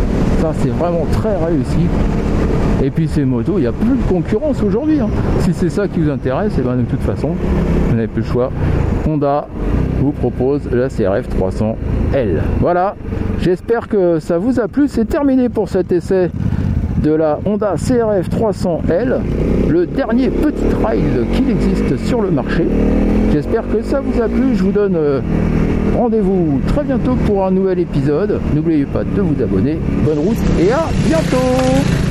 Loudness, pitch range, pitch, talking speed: -15 LUFS, 125-200 Hz, 155 Hz, 170 wpm